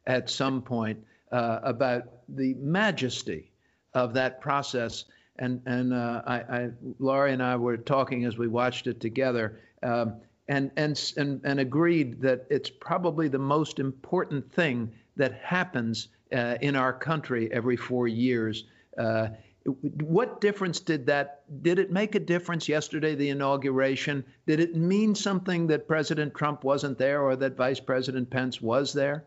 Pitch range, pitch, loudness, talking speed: 120-150 Hz, 135 Hz, -28 LUFS, 155 wpm